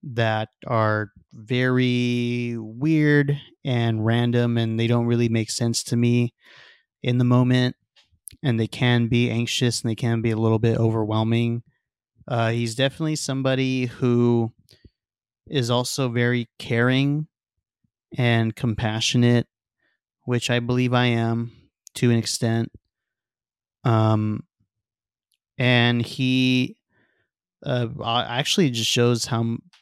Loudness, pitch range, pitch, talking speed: -22 LUFS, 115-125 Hz, 120 Hz, 115 wpm